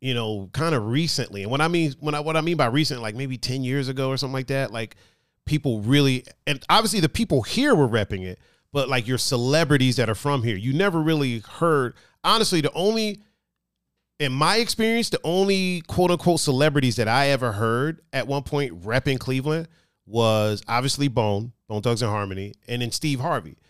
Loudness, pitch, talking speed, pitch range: -23 LUFS, 135 Hz, 200 wpm, 120-155 Hz